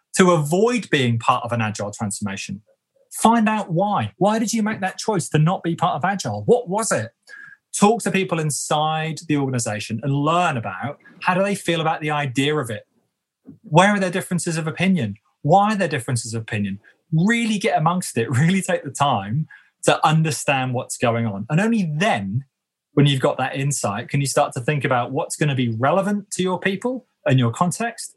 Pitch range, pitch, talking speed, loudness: 130-195 Hz, 155 Hz, 200 wpm, -21 LUFS